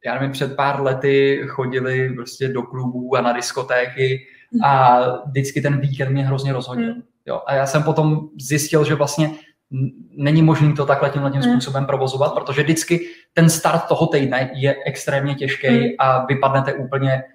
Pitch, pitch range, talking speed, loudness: 140 Hz, 130-150 Hz, 165 wpm, -19 LUFS